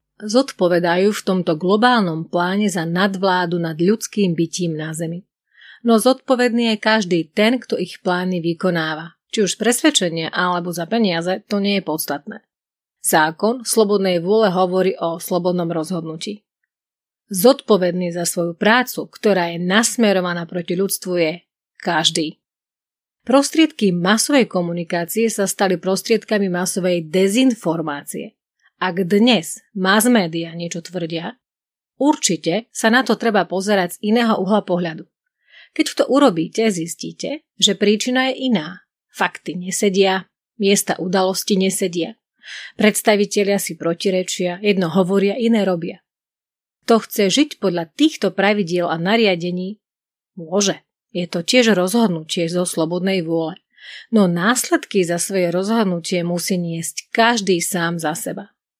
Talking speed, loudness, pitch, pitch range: 120 wpm, -18 LUFS, 190 Hz, 175-220 Hz